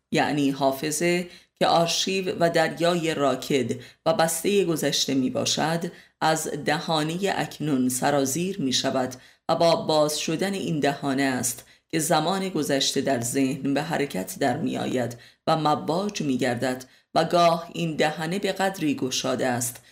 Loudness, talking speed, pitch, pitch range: -24 LUFS, 140 wpm, 150 Hz, 135-165 Hz